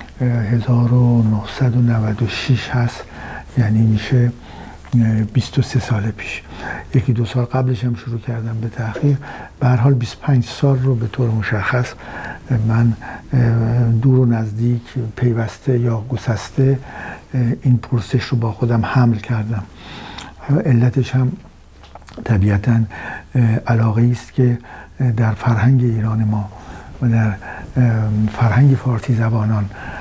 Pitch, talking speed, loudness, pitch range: 120 Hz, 110 wpm, -17 LUFS, 110-125 Hz